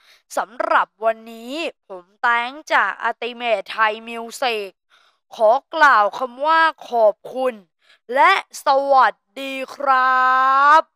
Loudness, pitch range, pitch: -18 LUFS, 230-285 Hz, 255 Hz